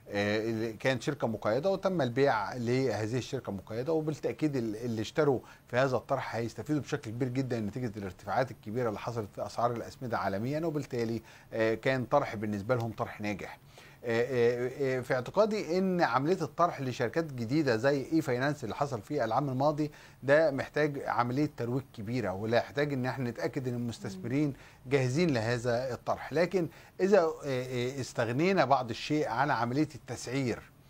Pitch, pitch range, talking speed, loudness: 130 Hz, 115-150 Hz, 140 wpm, -31 LUFS